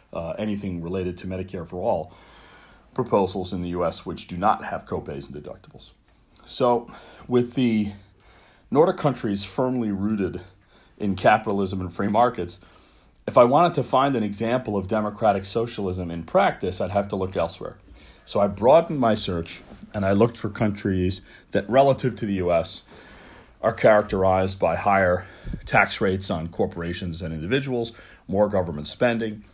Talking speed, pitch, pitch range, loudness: 150 wpm, 100 Hz, 90-115 Hz, -23 LUFS